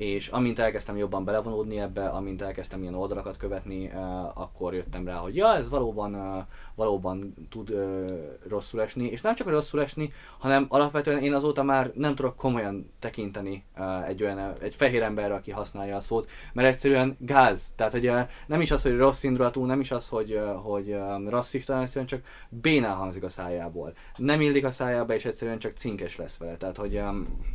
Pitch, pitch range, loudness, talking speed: 110 Hz, 95-130 Hz, -28 LUFS, 175 wpm